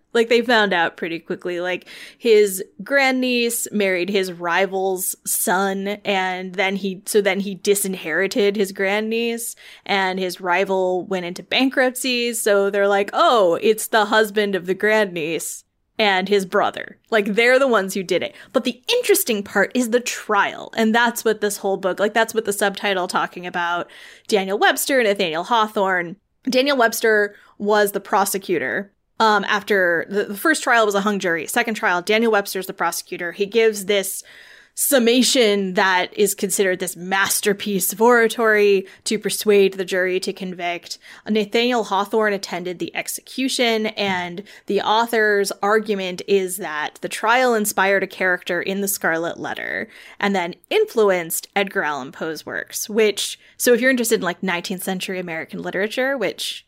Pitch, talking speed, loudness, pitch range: 200 Hz, 160 wpm, -19 LUFS, 190-225 Hz